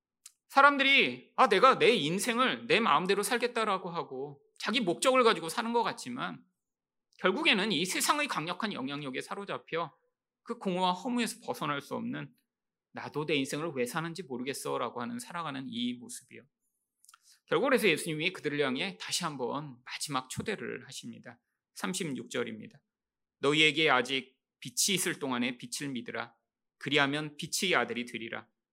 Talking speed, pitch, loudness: 330 characters per minute, 175 Hz, -30 LUFS